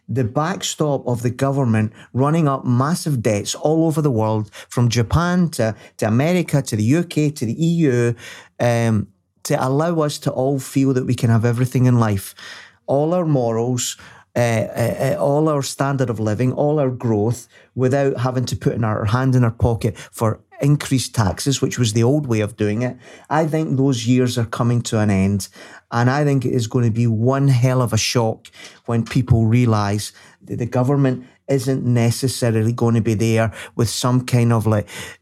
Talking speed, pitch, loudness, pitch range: 190 wpm, 125 Hz, -19 LUFS, 115-135 Hz